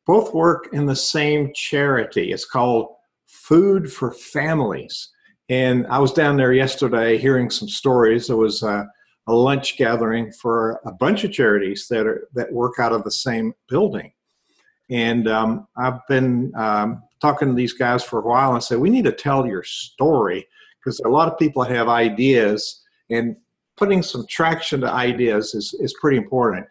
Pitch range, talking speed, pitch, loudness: 115-145 Hz, 175 wpm, 125 Hz, -19 LUFS